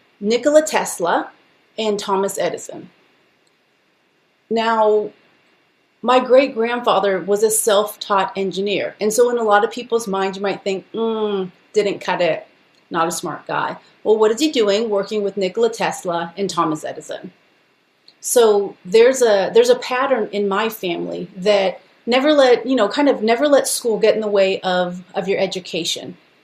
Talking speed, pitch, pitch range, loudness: 160 wpm, 215 Hz, 195-250 Hz, -18 LUFS